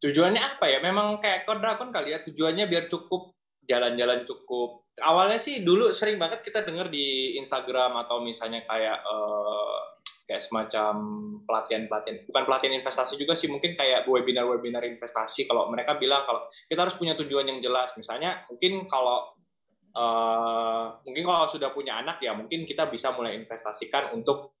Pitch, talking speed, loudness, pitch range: 135 Hz, 160 wpm, -27 LUFS, 120-175 Hz